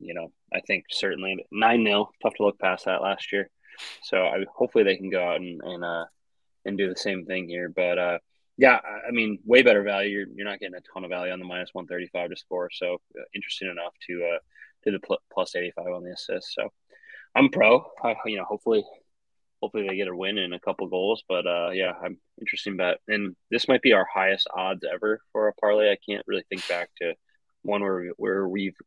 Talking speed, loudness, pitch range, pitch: 230 wpm, -25 LUFS, 90-110 Hz, 95 Hz